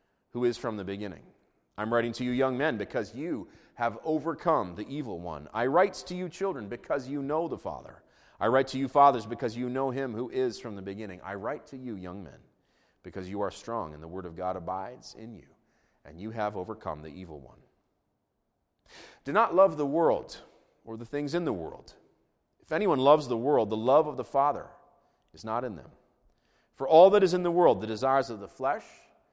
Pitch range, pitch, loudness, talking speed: 100-140 Hz, 120 Hz, -28 LUFS, 215 wpm